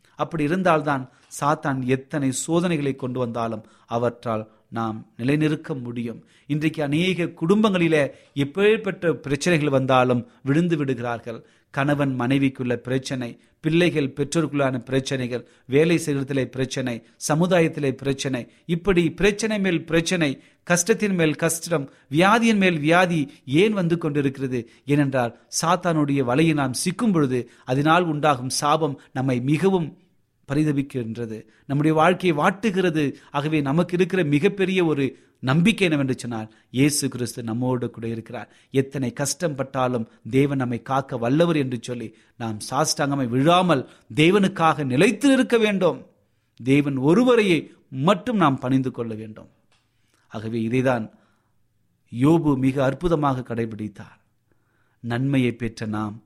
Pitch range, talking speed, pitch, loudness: 120-165 Hz, 110 wpm, 140 Hz, -22 LUFS